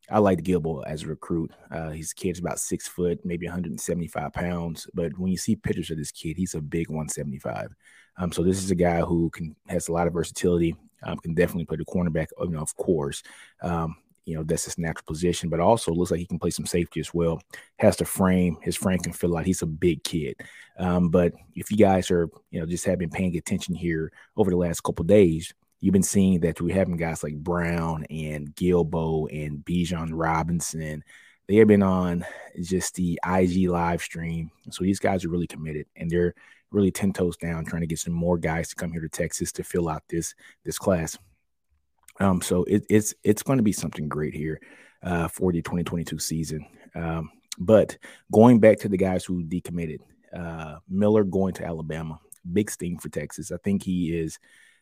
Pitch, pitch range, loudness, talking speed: 85 Hz, 80-90 Hz, -25 LUFS, 210 wpm